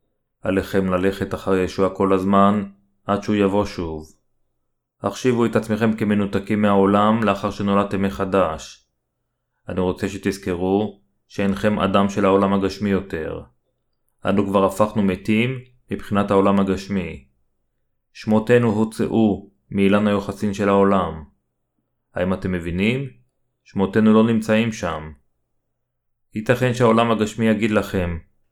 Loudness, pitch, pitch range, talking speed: -20 LUFS, 100 Hz, 95-110 Hz, 110 wpm